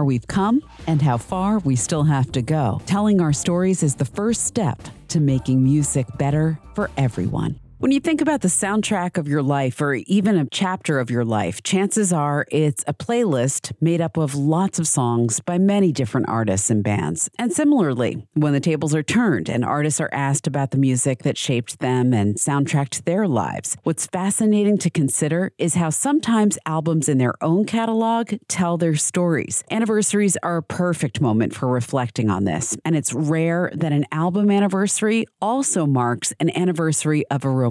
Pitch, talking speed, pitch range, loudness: 155 Hz, 185 wpm, 135-190 Hz, -20 LUFS